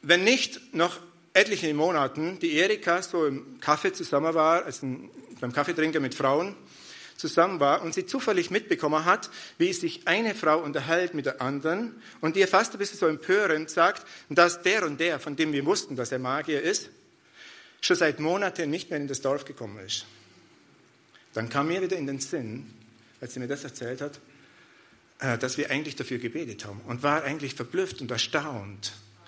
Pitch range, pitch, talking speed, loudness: 135-185 Hz, 155 Hz, 180 wpm, -27 LUFS